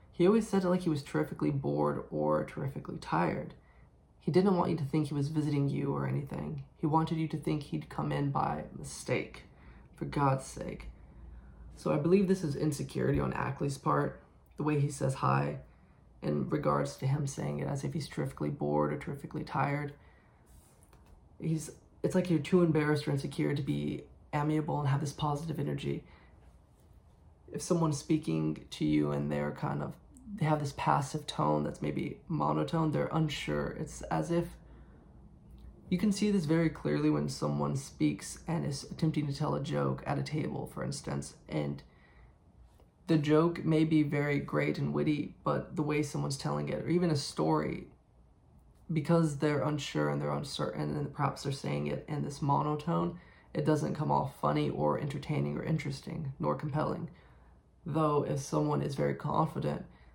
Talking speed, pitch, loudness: 175 wpm, 140 Hz, -33 LUFS